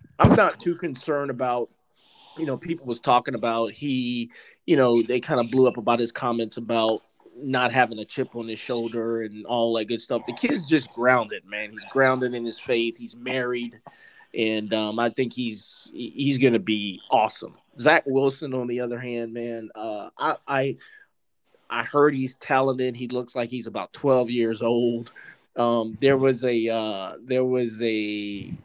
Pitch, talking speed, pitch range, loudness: 120 Hz, 180 wpm, 115-130 Hz, -24 LUFS